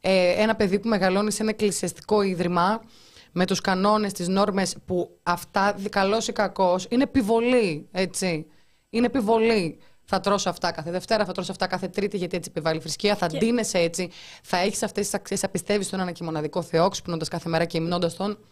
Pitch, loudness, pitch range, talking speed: 190 Hz, -24 LUFS, 175-210 Hz, 230 wpm